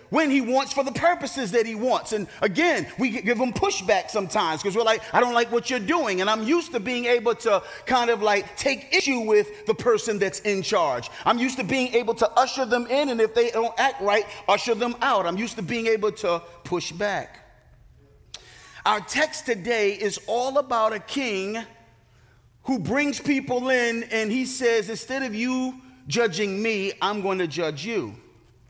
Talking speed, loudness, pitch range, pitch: 195 wpm, -24 LUFS, 205-255 Hz, 230 Hz